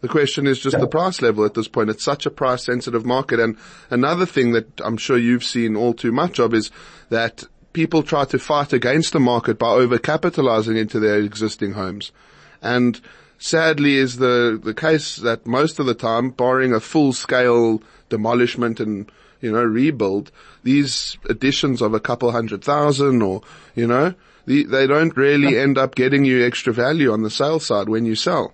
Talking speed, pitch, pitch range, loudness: 190 wpm, 125 Hz, 115-140 Hz, -18 LUFS